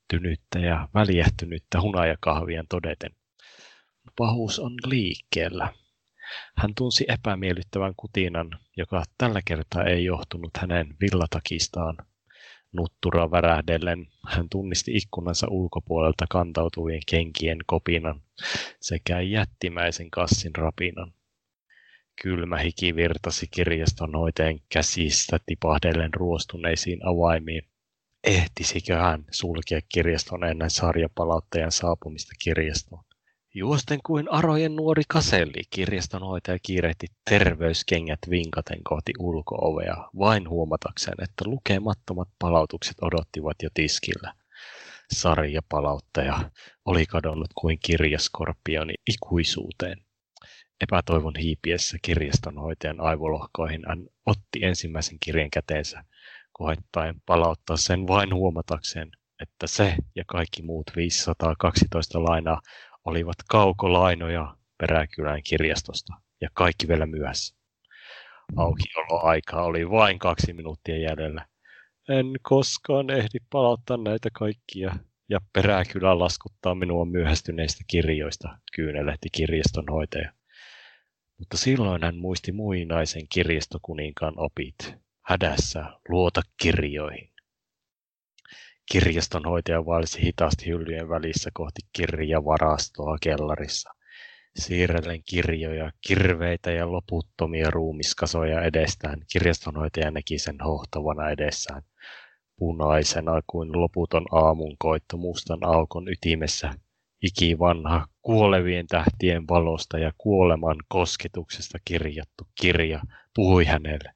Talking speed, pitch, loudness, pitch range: 90 wpm, 85 Hz, -25 LUFS, 80-90 Hz